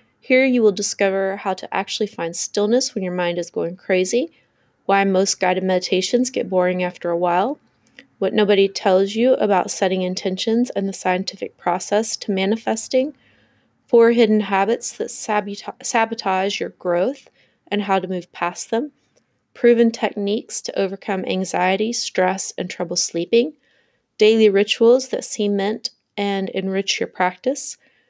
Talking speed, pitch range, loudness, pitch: 145 wpm, 185-230 Hz, -20 LUFS, 200 Hz